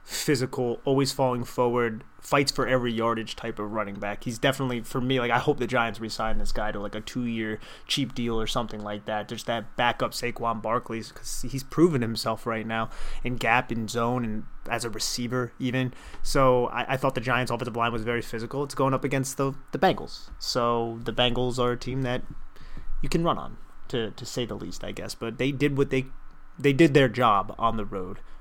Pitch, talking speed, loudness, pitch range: 120 Hz, 215 wpm, -27 LUFS, 110-130 Hz